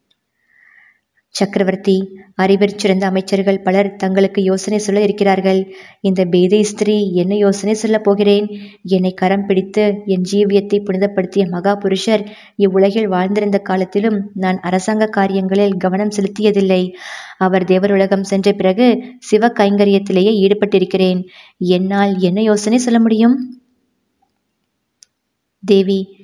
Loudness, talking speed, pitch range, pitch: -15 LUFS, 105 wpm, 190-210 Hz, 200 Hz